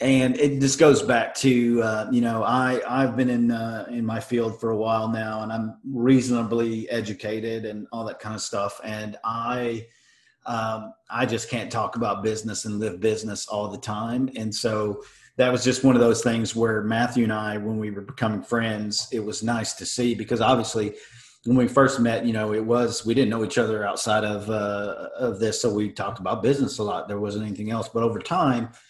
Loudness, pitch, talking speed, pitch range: -24 LUFS, 115 Hz, 215 wpm, 110-120 Hz